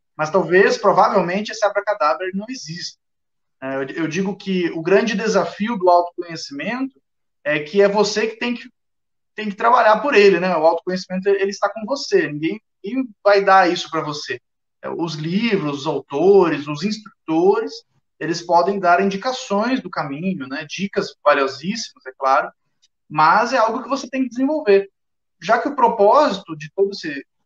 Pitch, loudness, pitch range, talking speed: 200 Hz, -18 LUFS, 175-225 Hz, 160 wpm